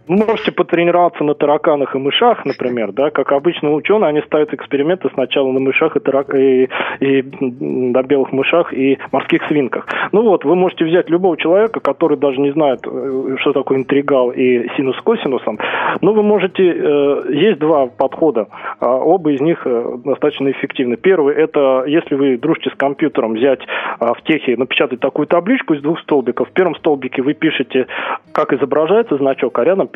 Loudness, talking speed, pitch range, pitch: -15 LUFS, 165 wpm, 135-165 Hz, 140 Hz